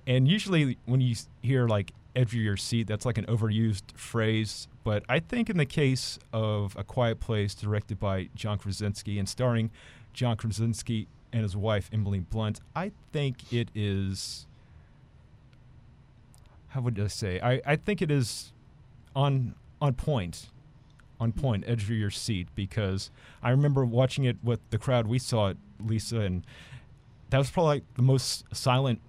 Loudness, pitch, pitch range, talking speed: -29 LUFS, 120 Hz, 105-130 Hz, 165 wpm